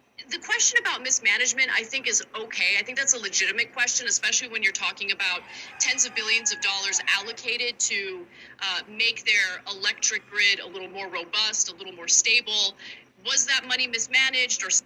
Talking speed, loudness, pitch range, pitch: 180 wpm, -23 LUFS, 195-260 Hz, 230 Hz